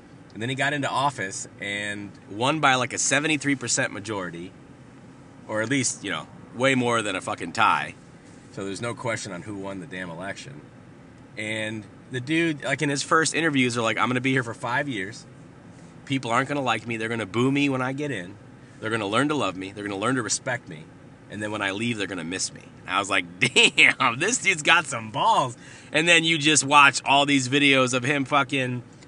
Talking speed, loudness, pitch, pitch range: 220 wpm, -23 LUFS, 130 Hz, 110-140 Hz